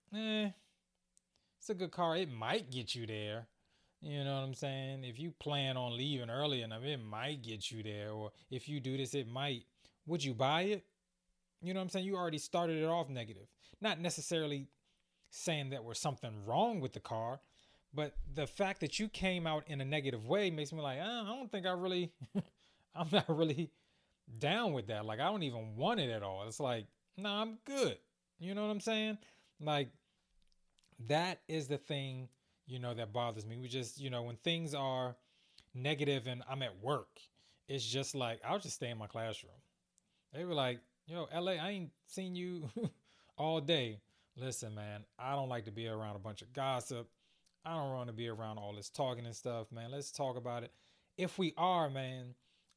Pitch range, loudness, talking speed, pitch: 120-170 Hz, -40 LUFS, 200 wpm, 140 Hz